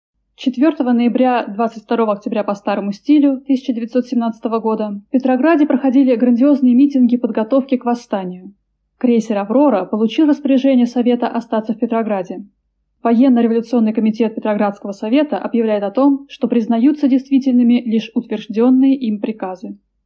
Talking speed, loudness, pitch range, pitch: 115 wpm, -16 LUFS, 220-260 Hz, 240 Hz